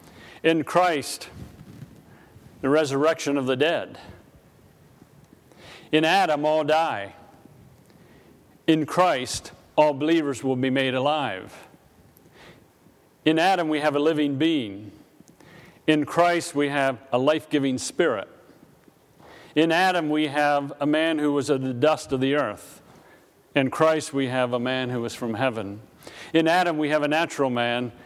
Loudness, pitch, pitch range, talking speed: -23 LUFS, 145 Hz, 130-155 Hz, 140 wpm